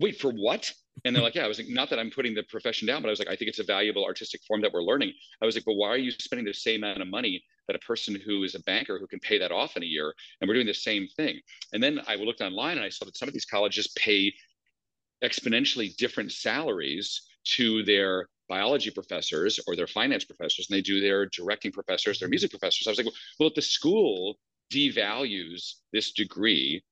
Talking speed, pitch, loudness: 245 wpm, 130 Hz, -28 LUFS